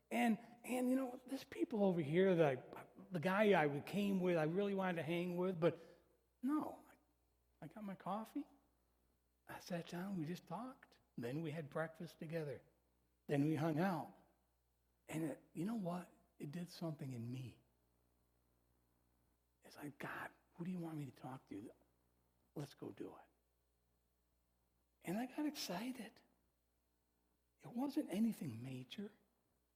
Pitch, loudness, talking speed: 160 Hz, -43 LUFS, 155 wpm